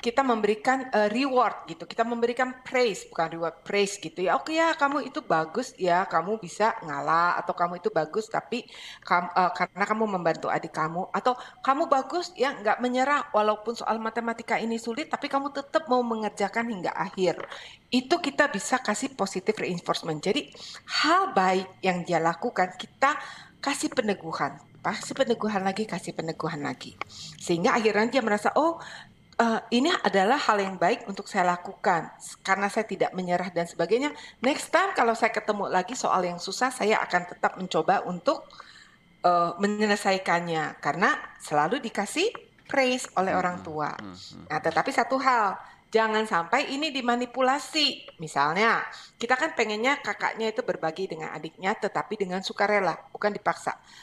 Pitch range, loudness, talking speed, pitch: 180-255 Hz, -26 LUFS, 155 wpm, 210 Hz